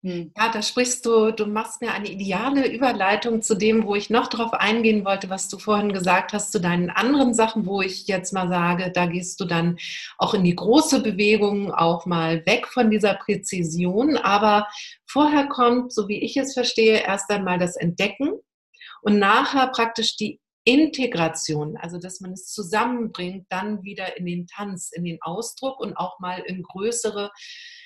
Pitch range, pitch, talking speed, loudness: 185-230 Hz, 205 Hz, 175 wpm, -22 LUFS